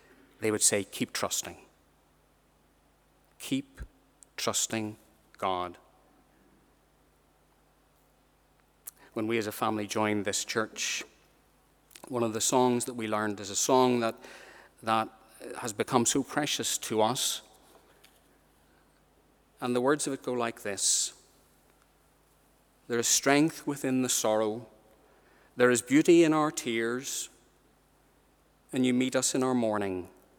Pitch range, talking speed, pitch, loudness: 100-130 Hz, 120 wpm, 110 Hz, -29 LUFS